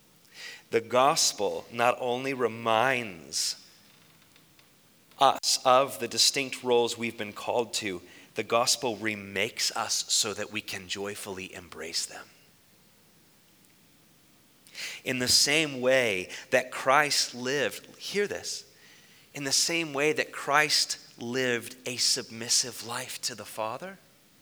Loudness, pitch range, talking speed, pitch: -27 LUFS, 110-135 Hz, 115 wpm, 120 Hz